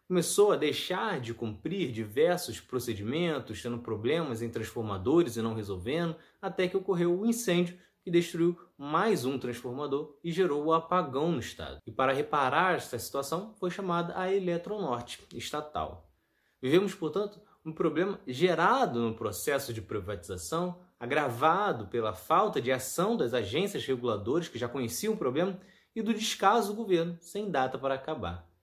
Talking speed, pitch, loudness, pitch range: 155 wpm, 160 Hz, -31 LUFS, 120-185 Hz